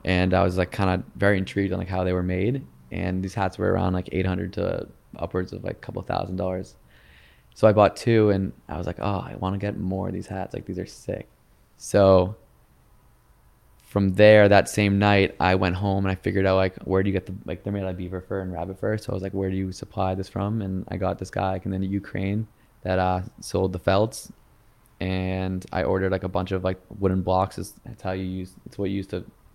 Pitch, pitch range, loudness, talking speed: 95 Hz, 95-100 Hz, -24 LUFS, 250 wpm